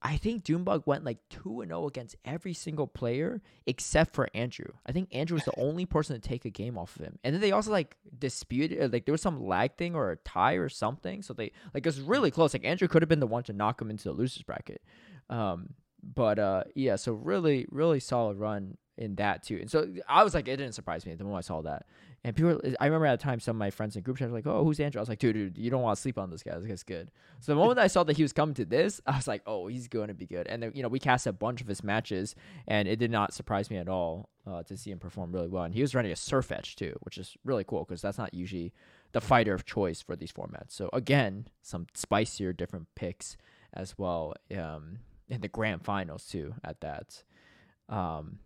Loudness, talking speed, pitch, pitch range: -31 LUFS, 270 wpm, 120 Hz, 100-145 Hz